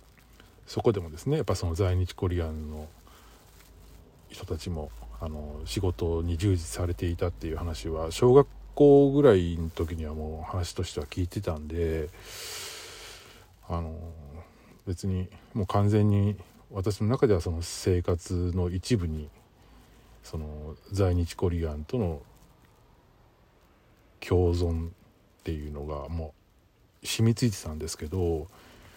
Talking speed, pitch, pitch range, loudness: 245 characters per minute, 90 Hz, 80-100 Hz, -28 LUFS